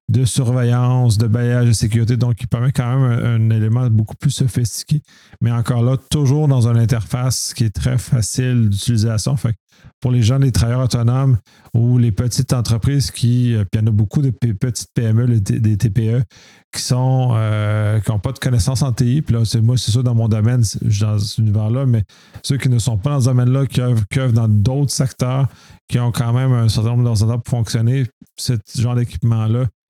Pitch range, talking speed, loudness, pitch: 115-130 Hz, 215 wpm, -17 LUFS, 120 Hz